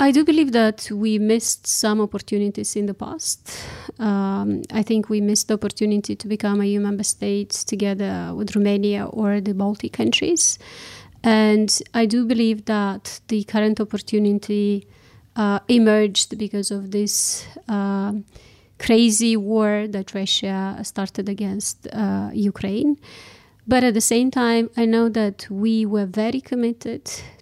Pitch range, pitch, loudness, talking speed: 205-225 Hz, 210 Hz, -20 LUFS, 140 wpm